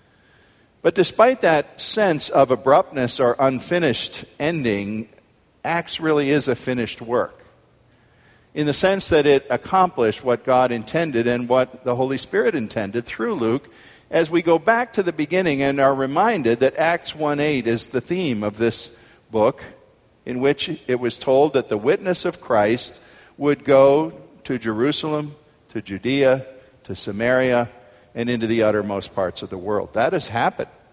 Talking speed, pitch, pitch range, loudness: 155 wpm, 130 Hz, 115-150 Hz, -20 LUFS